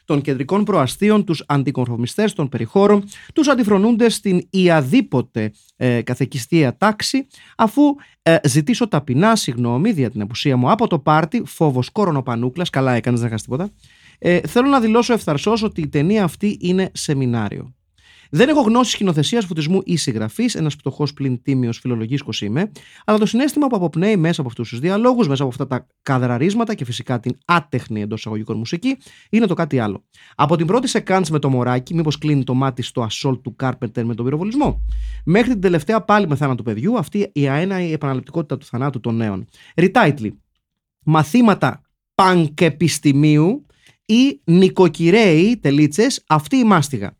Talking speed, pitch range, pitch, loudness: 160 wpm, 125-205 Hz, 155 Hz, -18 LUFS